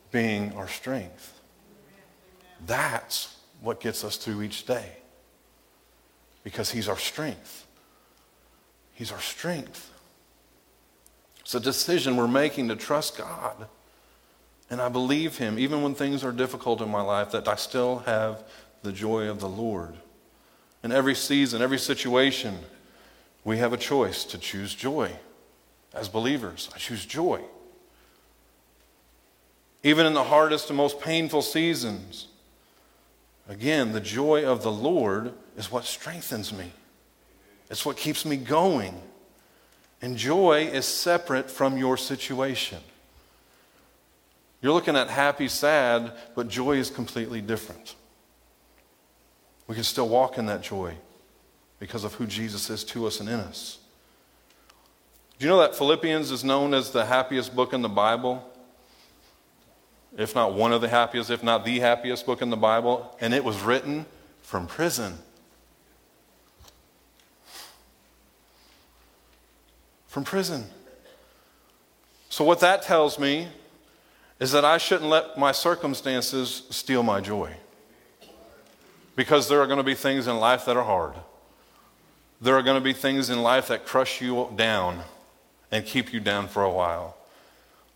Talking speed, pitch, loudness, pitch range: 140 wpm, 125 Hz, -25 LUFS, 110-140 Hz